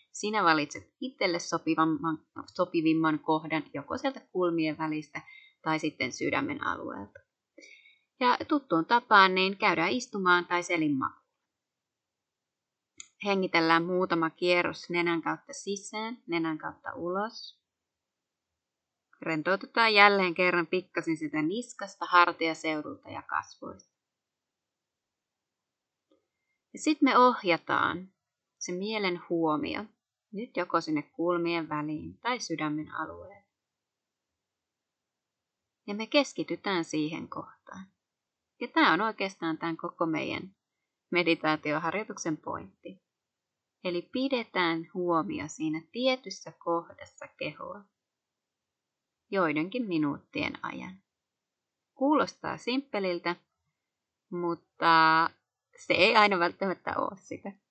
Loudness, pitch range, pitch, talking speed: -28 LUFS, 165-210 Hz, 175 Hz, 90 wpm